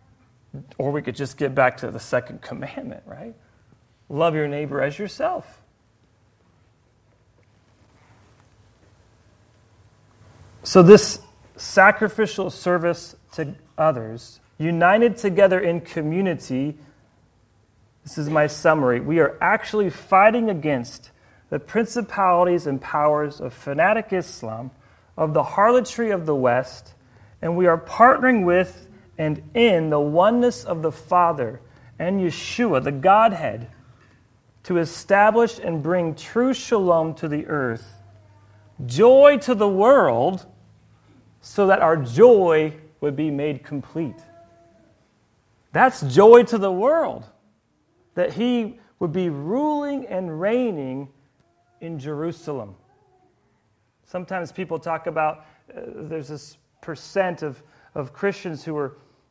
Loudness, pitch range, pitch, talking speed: -20 LUFS, 120-185 Hz, 150 Hz, 115 wpm